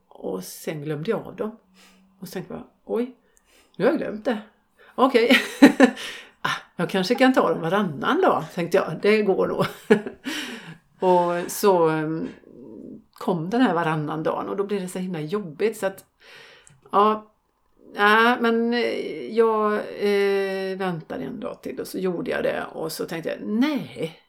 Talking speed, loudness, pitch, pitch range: 160 wpm, -23 LUFS, 205 Hz, 185-235 Hz